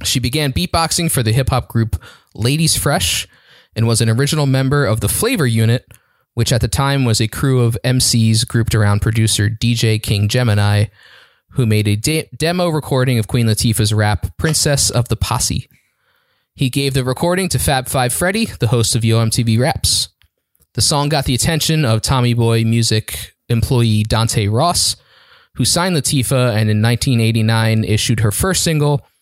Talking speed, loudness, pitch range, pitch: 175 wpm, -15 LUFS, 110-140 Hz, 120 Hz